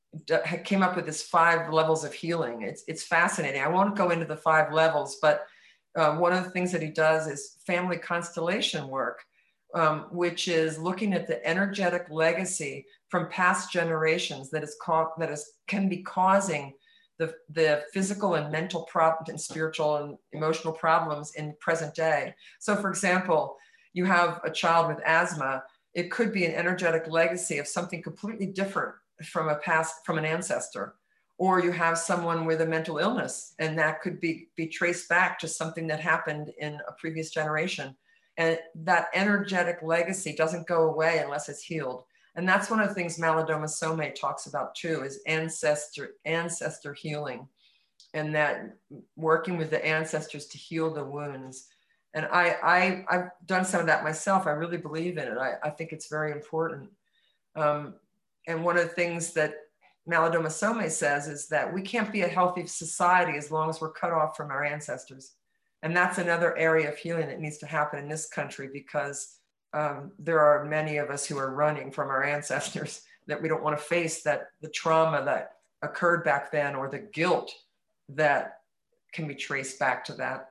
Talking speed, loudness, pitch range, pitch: 180 wpm, -28 LUFS, 150-175 Hz, 160 Hz